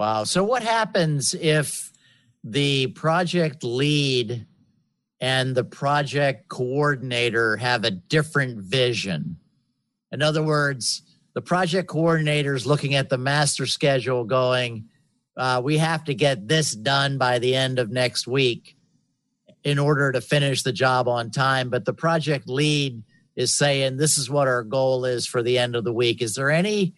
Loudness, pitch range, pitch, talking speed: -22 LUFS, 125-150 Hz, 135 Hz, 160 wpm